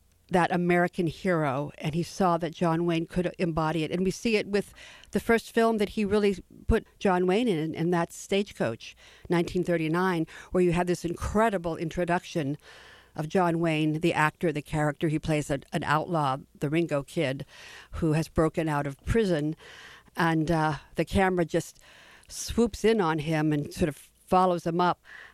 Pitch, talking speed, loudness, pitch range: 170 Hz, 175 wpm, -27 LUFS, 155-180 Hz